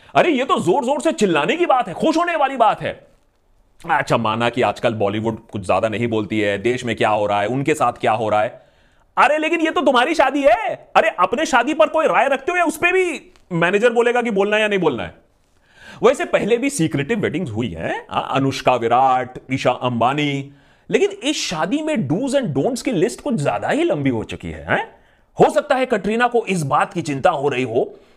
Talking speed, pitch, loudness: 220 wpm, 200 Hz, -18 LUFS